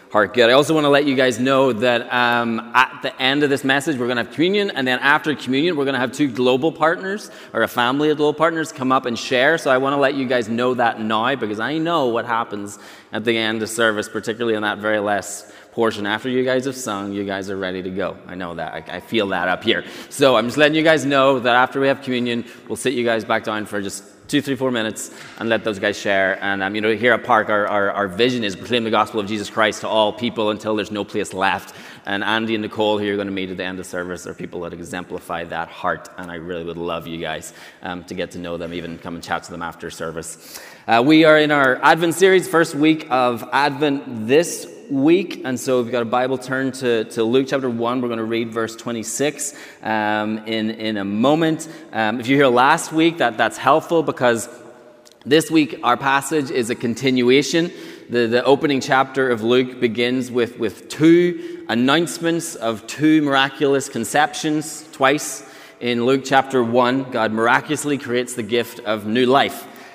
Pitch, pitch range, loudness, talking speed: 120 Hz, 110-140 Hz, -19 LUFS, 230 wpm